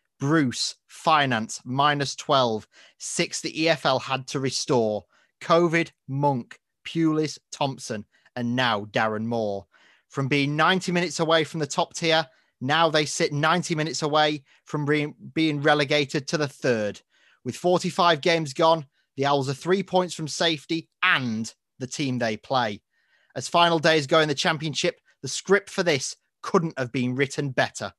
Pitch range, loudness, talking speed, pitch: 130-165 Hz, -24 LUFS, 155 wpm, 150 Hz